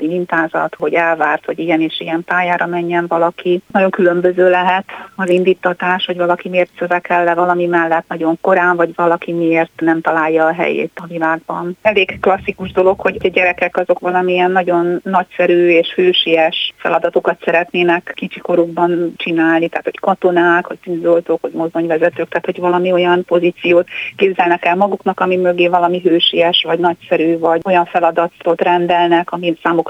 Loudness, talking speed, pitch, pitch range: -14 LUFS, 155 wpm, 175 Hz, 170-180 Hz